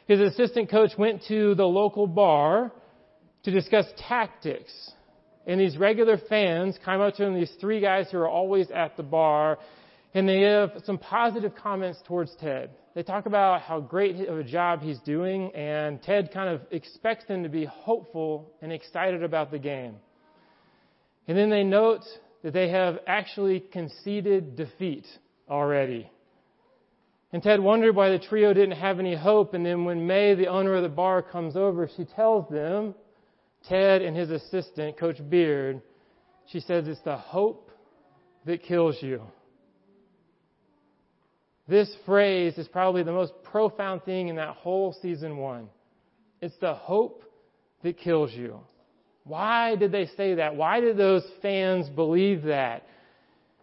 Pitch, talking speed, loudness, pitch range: 185 Hz, 155 wpm, -25 LUFS, 165-205 Hz